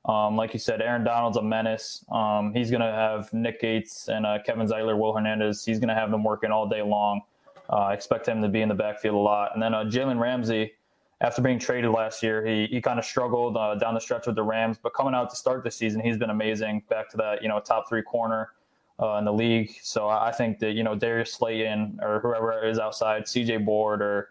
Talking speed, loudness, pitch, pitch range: 245 wpm, -26 LUFS, 110 Hz, 105-115 Hz